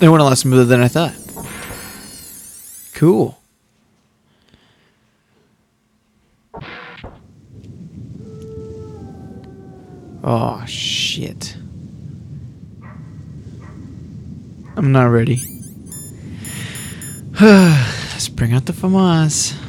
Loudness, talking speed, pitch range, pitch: -15 LUFS, 60 wpm, 115-150 Hz, 130 Hz